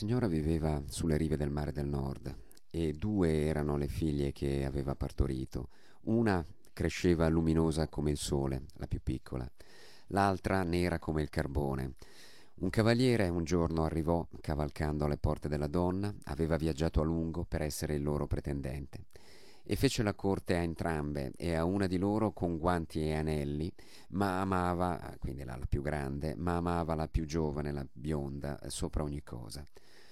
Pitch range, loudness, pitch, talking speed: 75-90 Hz, -34 LUFS, 80 Hz, 160 wpm